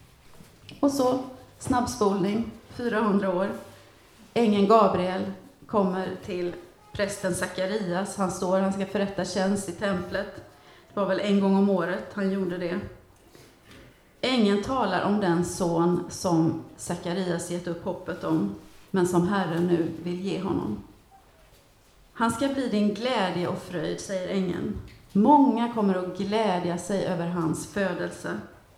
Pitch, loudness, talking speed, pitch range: 190 Hz, -26 LUFS, 135 wpm, 175-205 Hz